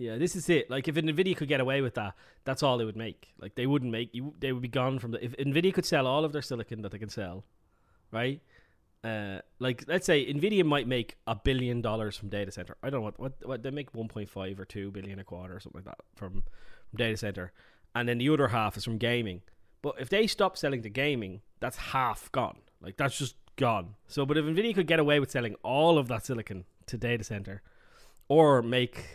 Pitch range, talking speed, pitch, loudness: 100-140 Hz, 245 wpm, 120 Hz, -30 LUFS